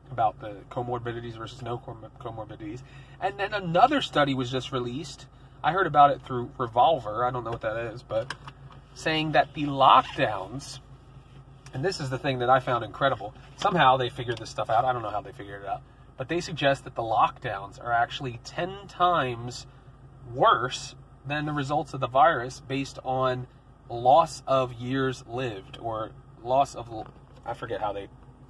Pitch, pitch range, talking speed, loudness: 130 Hz, 120-140 Hz, 175 wpm, -26 LUFS